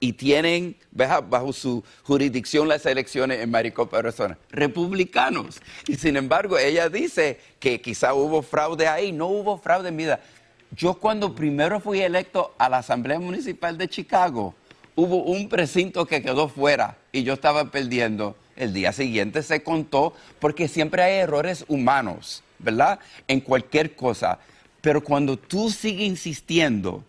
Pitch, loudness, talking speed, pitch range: 150 Hz, -23 LUFS, 150 wpm, 135-175 Hz